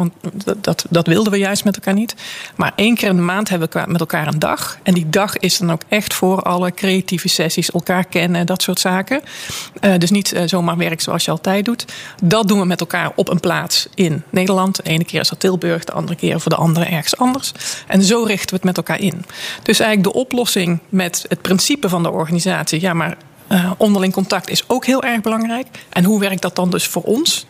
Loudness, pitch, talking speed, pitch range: -16 LUFS, 185 Hz, 235 wpm, 175-200 Hz